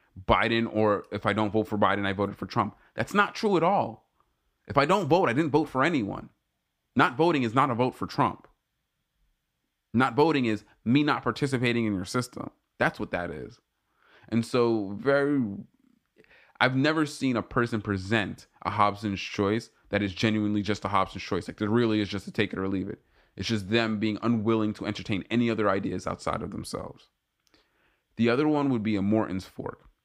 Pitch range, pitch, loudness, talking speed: 100-120 Hz, 110 Hz, -27 LUFS, 195 wpm